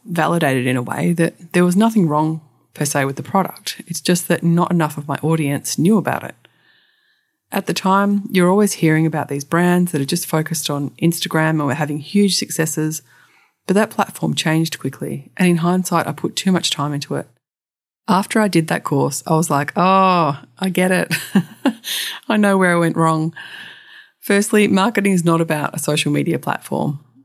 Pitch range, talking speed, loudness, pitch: 150-190 Hz, 190 wpm, -18 LUFS, 165 Hz